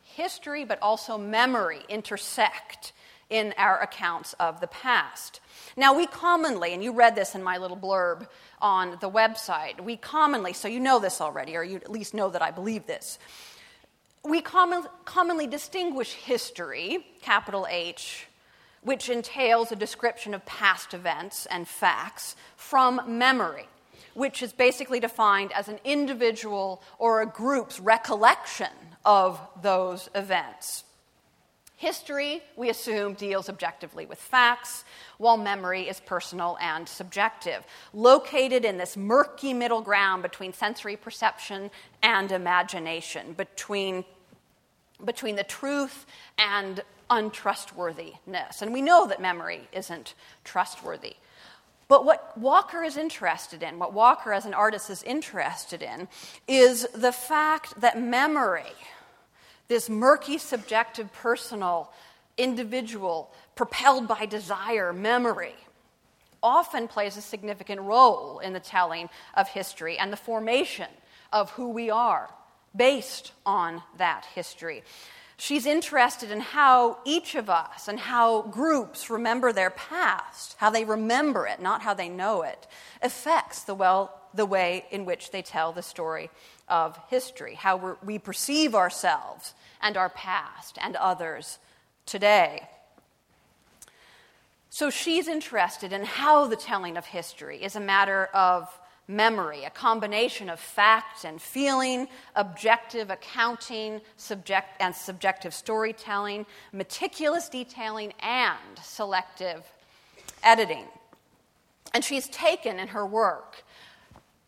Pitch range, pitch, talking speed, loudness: 190-255 Hz, 220 Hz, 125 wpm, -26 LUFS